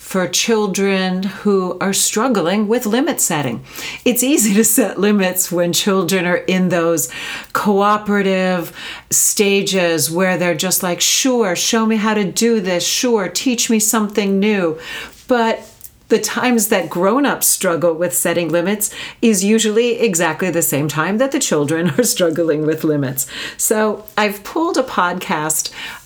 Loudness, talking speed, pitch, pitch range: -16 LUFS, 145 wpm, 195 Hz, 175-225 Hz